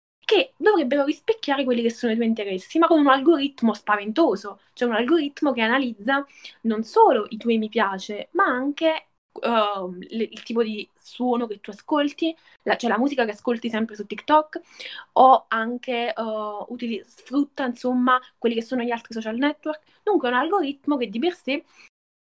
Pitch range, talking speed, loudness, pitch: 220-290 Hz, 180 wpm, -23 LUFS, 245 Hz